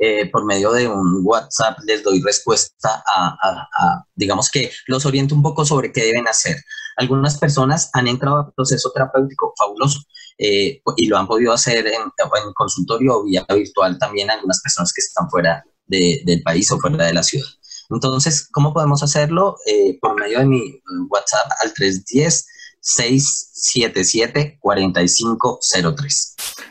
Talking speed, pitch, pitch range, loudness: 155 wpm, 135 Hz, 110-150 Hz, -17 LUFS